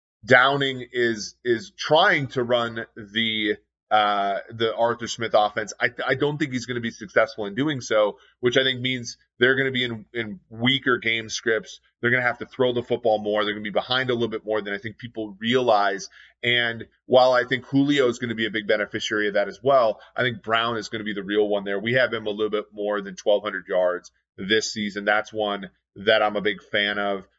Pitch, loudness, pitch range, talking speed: 115 Hz, -23 LUFS, 105-125 Hz, 235 wpm